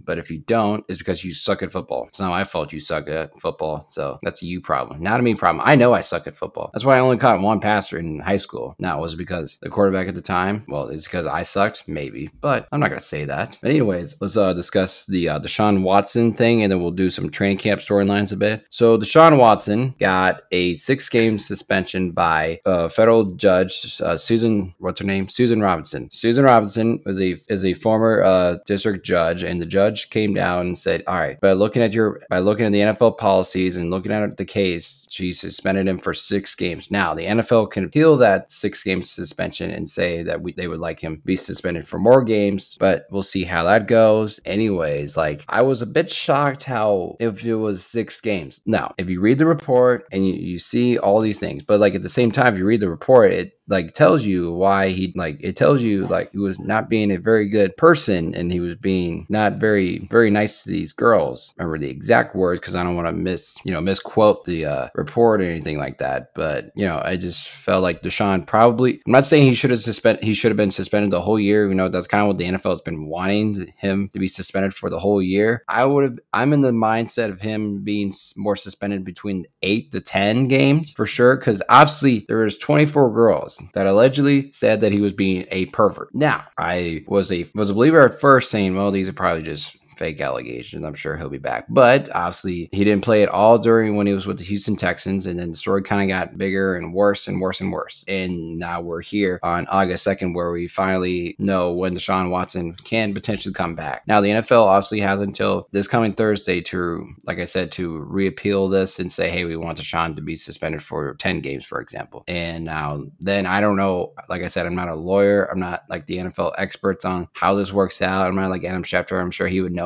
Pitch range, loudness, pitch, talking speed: 90-110 Hz, -19 LUFS, 100 Hz, 235 wpm